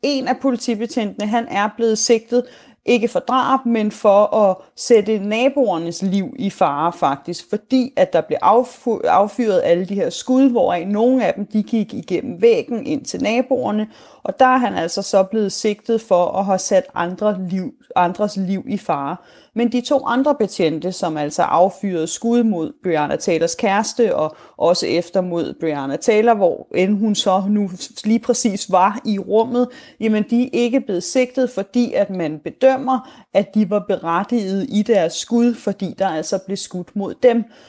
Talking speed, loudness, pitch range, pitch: 170 wpm, -18 LUFS, 190-245 Hz, 215 Hz